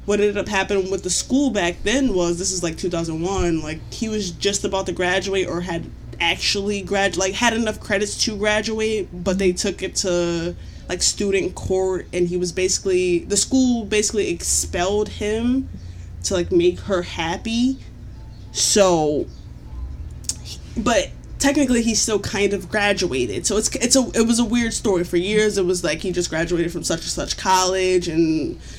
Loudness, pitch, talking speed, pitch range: -20 LUFS, 190 Hz, 175 wpm, 175-210 Hz